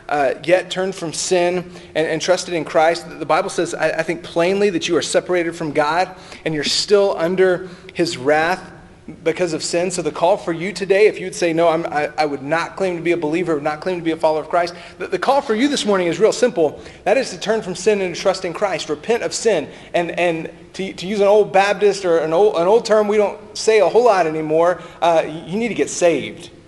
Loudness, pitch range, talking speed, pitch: -18 LUFS, 160-195 Hz, 245 wpm, 175 Hz